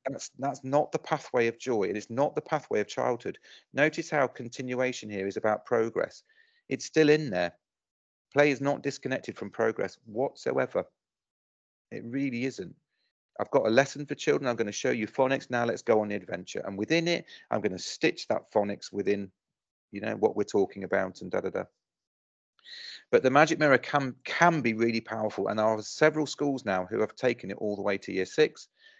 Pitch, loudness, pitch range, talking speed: 130 Hz, -29 LUFS, 105-145 Hz, 205 wpm